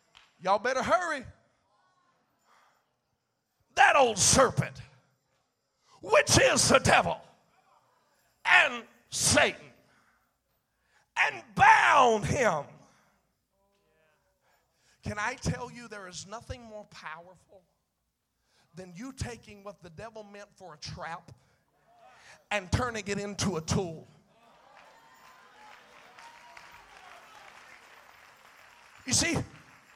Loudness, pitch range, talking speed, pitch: -25 LUFS, 180-225 Hz, 85 wpm, 205 Hz